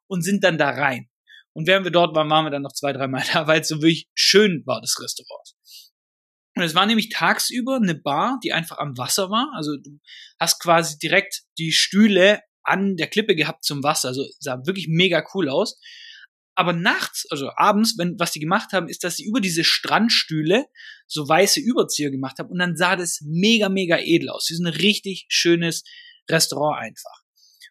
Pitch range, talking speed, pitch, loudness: 155-205 Hz, 200 wpm, 175 Hz, -20 LUFS